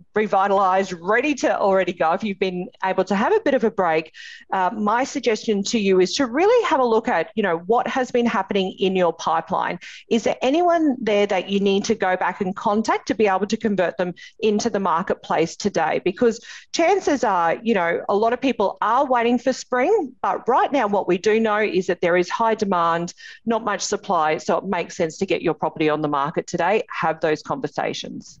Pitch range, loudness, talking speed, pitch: 185-240 Hz, -21 LUFS, 220 wpm, 205 Hz